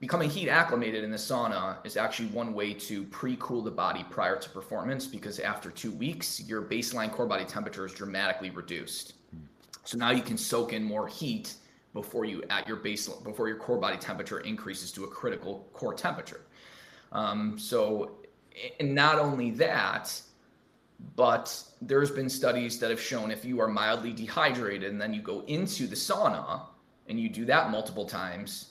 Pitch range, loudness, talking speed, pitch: 105-150 Hz, -31 LUFS, 175 wpm, 120 Hz